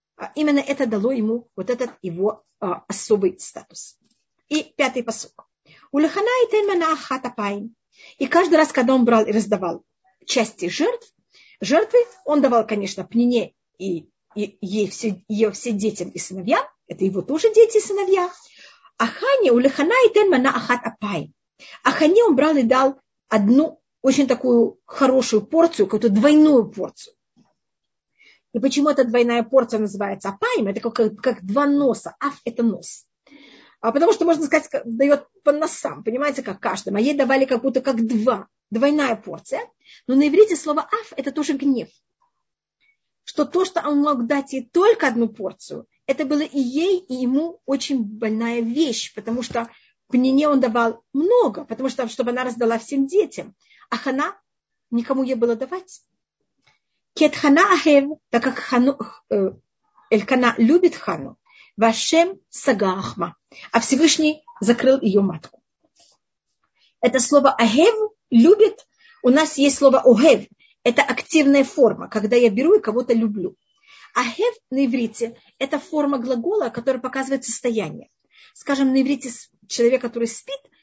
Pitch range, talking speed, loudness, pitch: 230-300 Hz, 145 wpm, -19 LUFS, 265 Hz